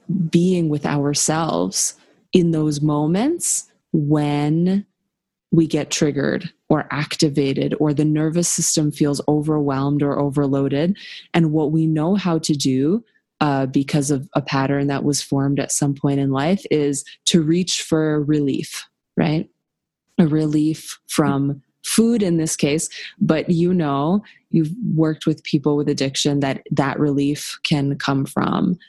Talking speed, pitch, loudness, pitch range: 140 wpm, 155 Hz, -20 LUFS, 145-170 Hz